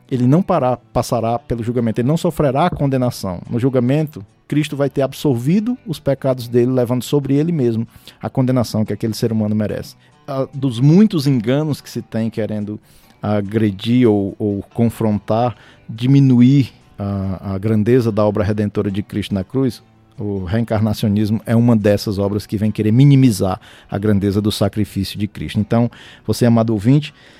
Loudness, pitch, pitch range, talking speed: -17 LUFS, 115 Hz, 105-130 Hz, 160 wpm